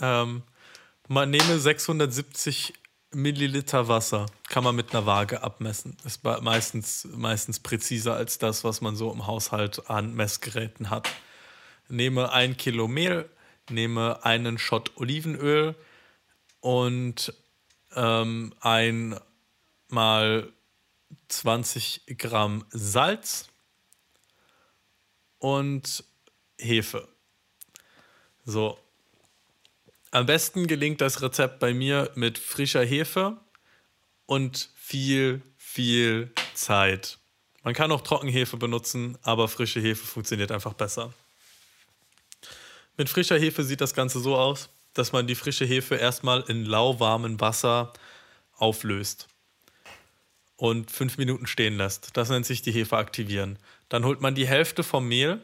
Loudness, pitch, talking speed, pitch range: -26 LUFS, 120 Hz, 115 wpm, 115-135 Hz